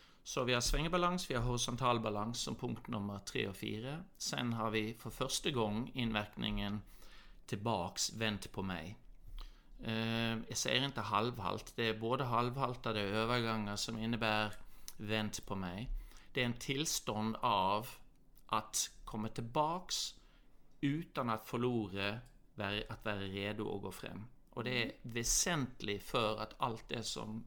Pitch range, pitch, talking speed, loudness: 105-125 Hz, 115 Hz, 140 wpm, -38 LUFS